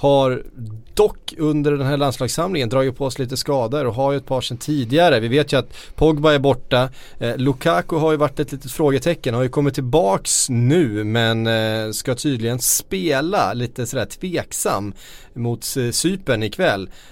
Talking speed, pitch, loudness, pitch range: 175 wpm, 135 Hz, -19 LUFS, 120-150 Hz